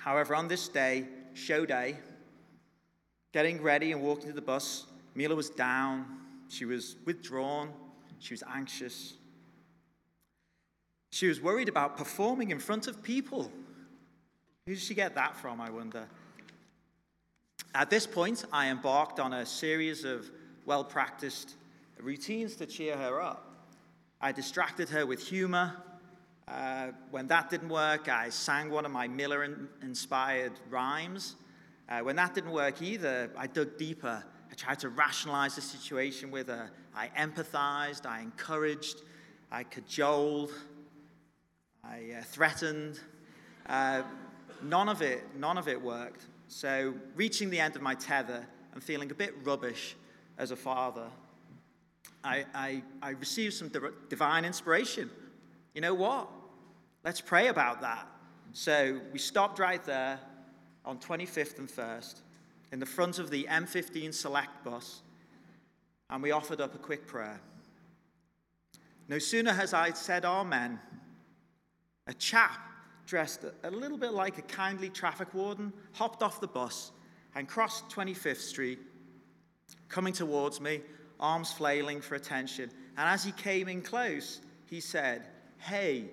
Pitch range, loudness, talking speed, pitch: 130-165 Hz, -33 LUFS, 140 wpm, 145 Hz